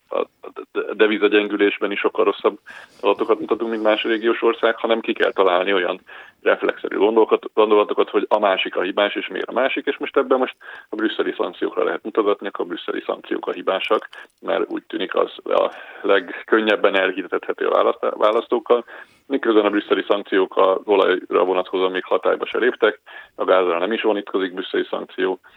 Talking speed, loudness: 160 wpm, -20 LUFS